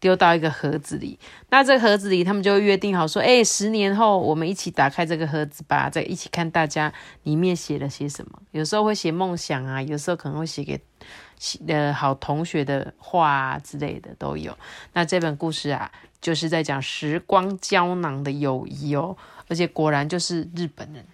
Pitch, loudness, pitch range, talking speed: 165 Hz, -22 LUFS, 150-180 Hz, 300 characters per minute